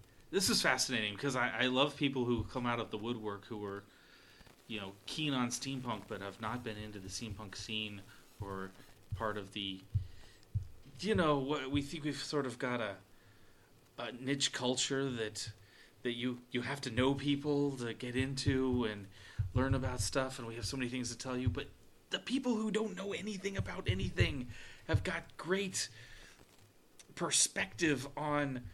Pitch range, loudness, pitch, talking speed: 105-140 Hz, -36 LUFS, 120 Hz, 175 wpm